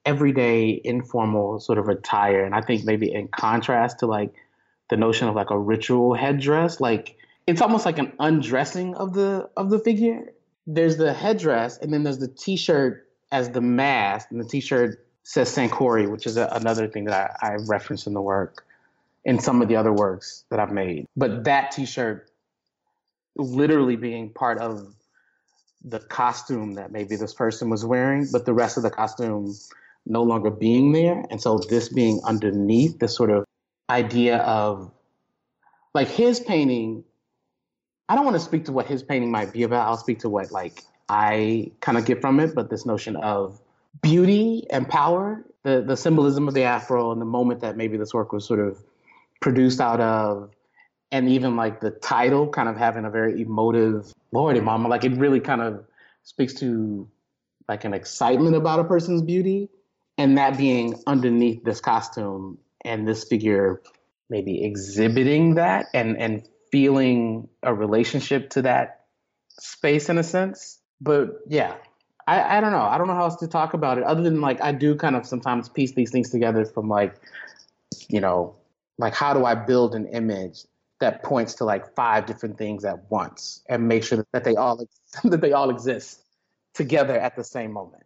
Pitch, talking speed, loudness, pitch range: 120 Hz, 180 wpm, -22 LUFS, 110-140 Hz